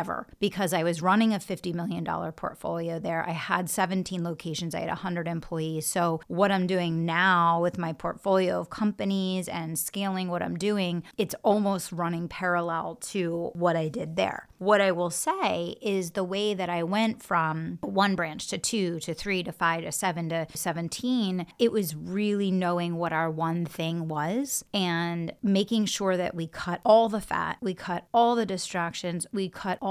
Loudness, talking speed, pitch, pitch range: -28 LUFS, 185 wpm, 180 Hz, 170-195 Hz